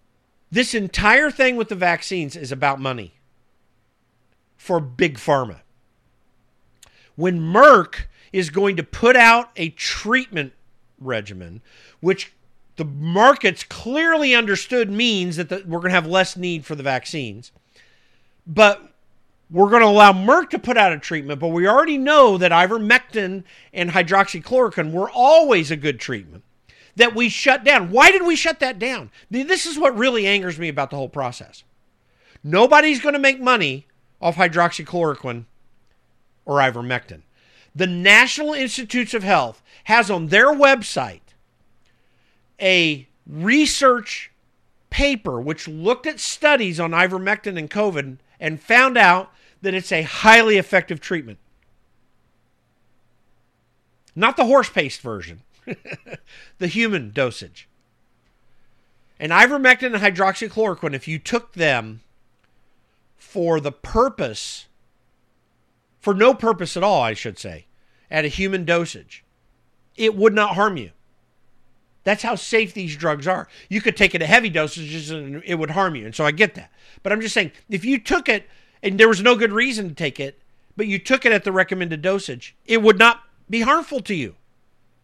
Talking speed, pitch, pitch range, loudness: 150 wpm, 185 Hz, 140-230 Hz, -17 LUFS